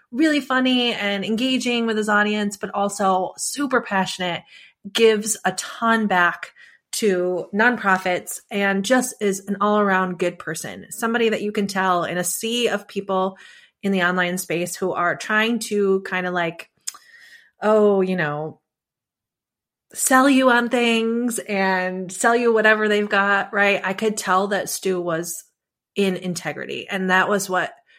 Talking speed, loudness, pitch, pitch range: 155 wpm, -20 LUFS, 200 Hz, 185-230 Hz